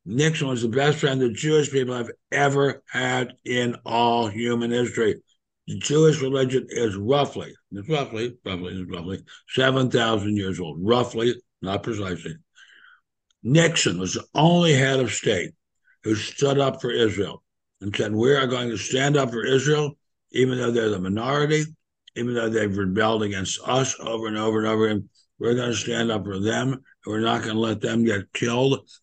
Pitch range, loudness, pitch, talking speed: 110-135 Hz, -23 LUFS, 120 Hz, 175 wpm